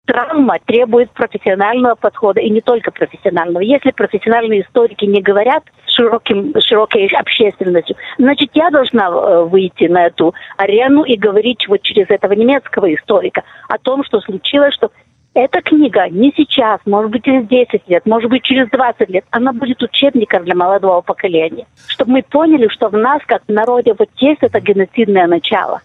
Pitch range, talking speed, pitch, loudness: 205-260 Hz, 160 wpm, 230 Hz, -12 LUFS